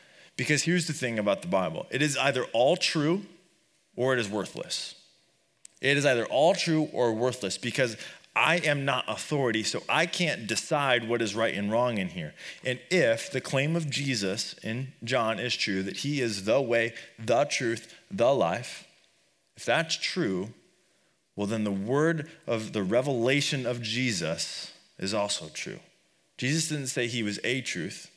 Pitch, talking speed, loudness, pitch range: 130 Hz, 170 wpm, -28 LUFS, 115-150 Hz